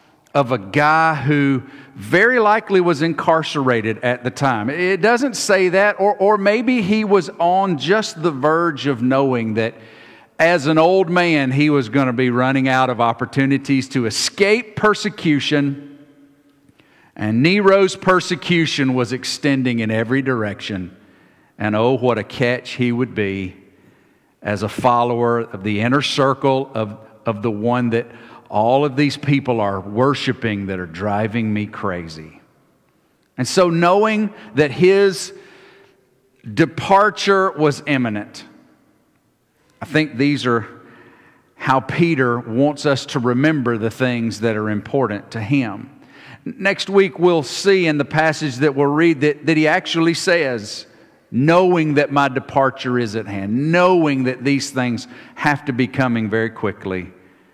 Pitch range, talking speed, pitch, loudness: 120-165 Hz, 145 wpm, 140 Hz, -17 LUFS